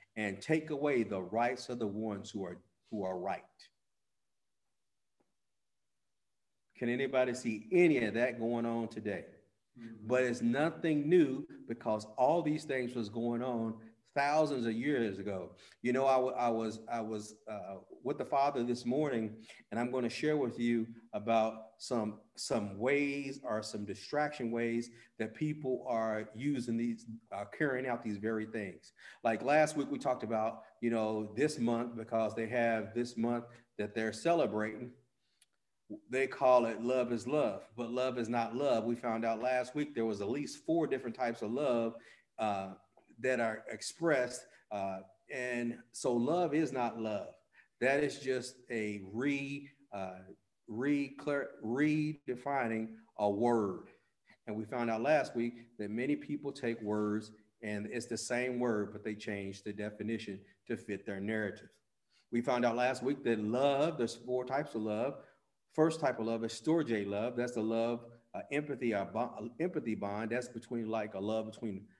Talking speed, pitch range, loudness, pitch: 165 wpm, 110-130 Hz, -35 LUFS, 115 Hz